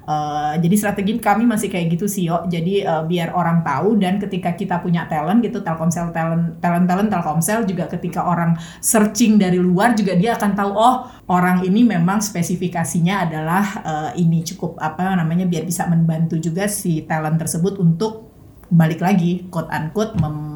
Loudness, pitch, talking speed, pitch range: -18 LUFS, 180 Hz, 170 wpm, 165-200 Hz